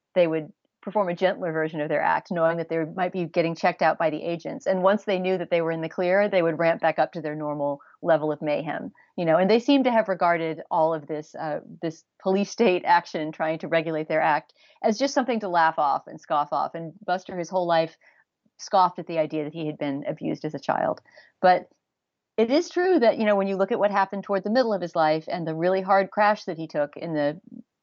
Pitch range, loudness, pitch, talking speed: 160-195 Hz, -24 LUFS, 175 Hz, 250 wpm